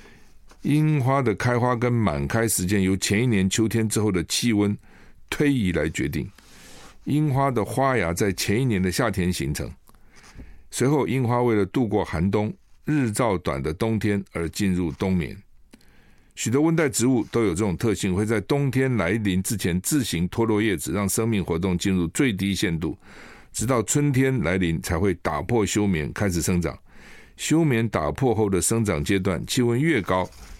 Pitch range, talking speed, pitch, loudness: 95-125 Hz, 250 characters per minute, 105 Hz, -23 LUFS